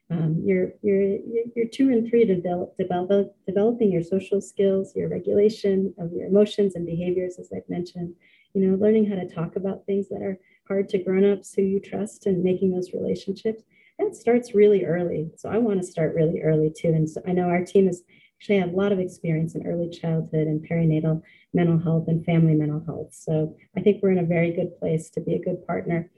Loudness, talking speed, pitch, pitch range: -24 LUFS, 215 wpm, 185 Hz, 170-200 Hz